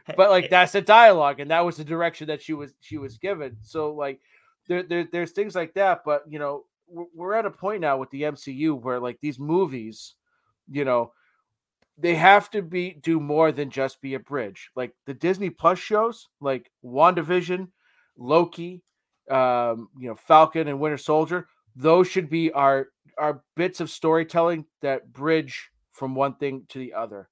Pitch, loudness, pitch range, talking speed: 155 Hz, -23 LUFS, 135-180 Hz, 180 wpm